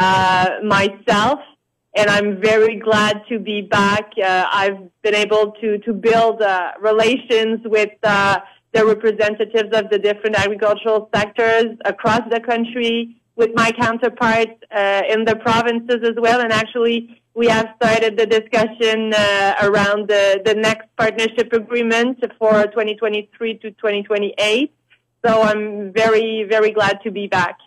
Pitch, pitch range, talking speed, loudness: 220 Hz, 210-230 Hz, 140 wpm, -17 LUFS